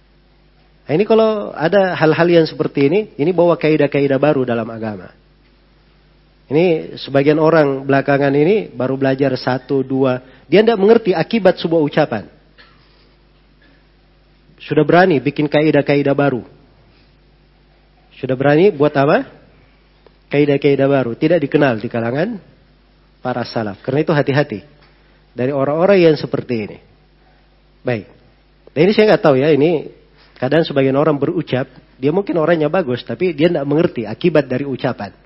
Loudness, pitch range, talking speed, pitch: -15 LUFS, 130-165 Hz, 130 wpm, 145 Hz